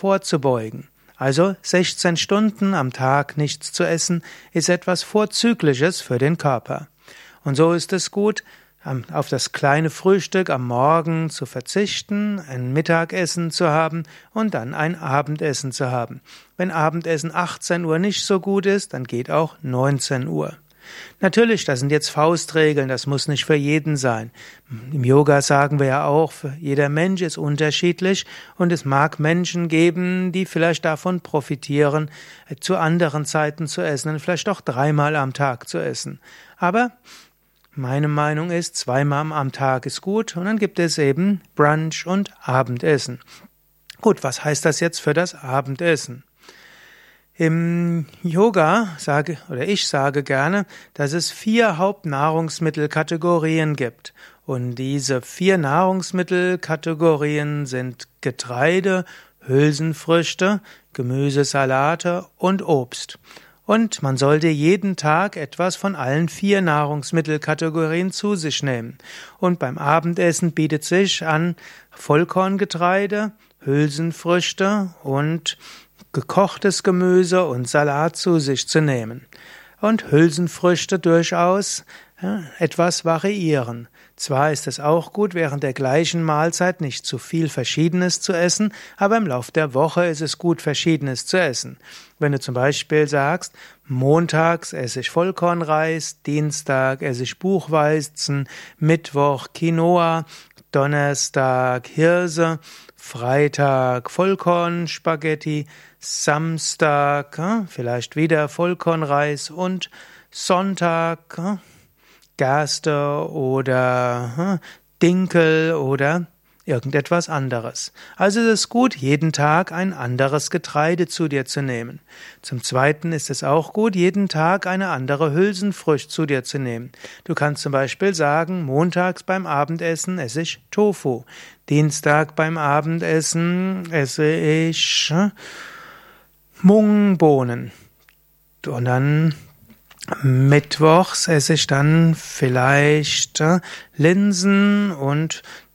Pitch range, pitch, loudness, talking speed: 145-180 Hz, 160 Hz, -20 LUFS, 120 wpm